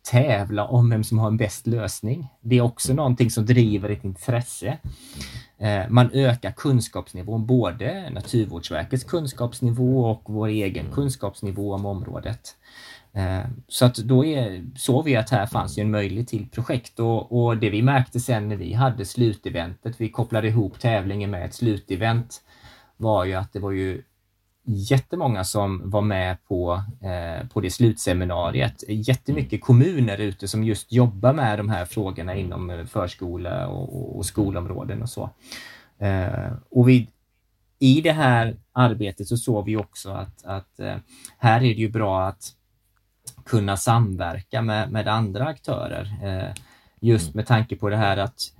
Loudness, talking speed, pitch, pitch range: -23 LUFS, 155 wpm, 110 Hz, 100-125 Hz